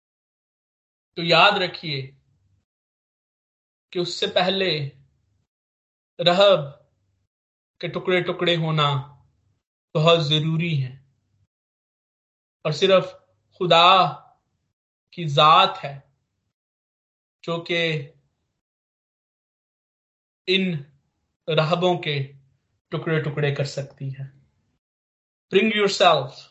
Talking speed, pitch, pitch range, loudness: 75 wpm, 150 Hz, 130-175 Hz, -20 LUFS